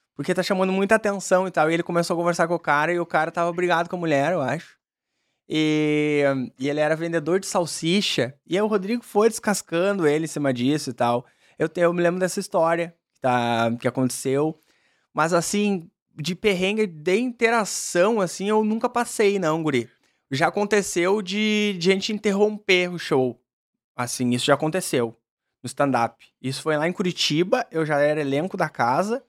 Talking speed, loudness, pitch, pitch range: 190 wpm, -23 LUFS, 170 Hz, 145-195 Hz